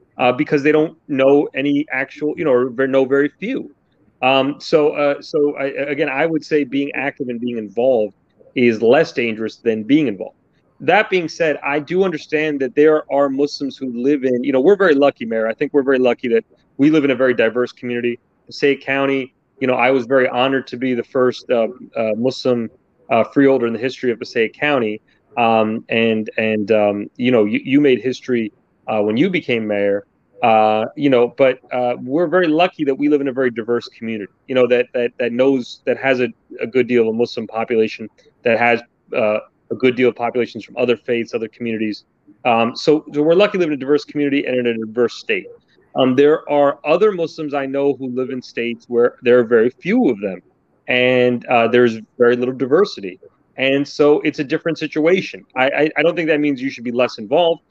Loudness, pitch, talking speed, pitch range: -17 LUFS, 130 Hz, 215 wpm, 120-145 Hz